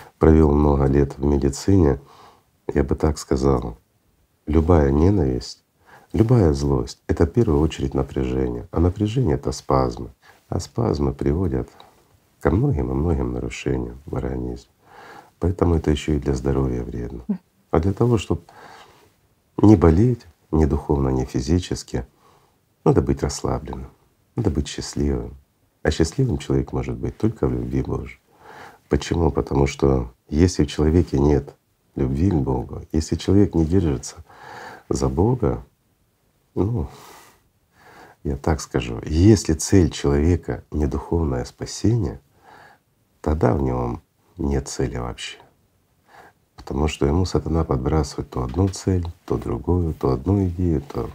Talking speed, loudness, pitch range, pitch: 130 wpm, -21 LUFS, 65-85 Hz, 75 Hz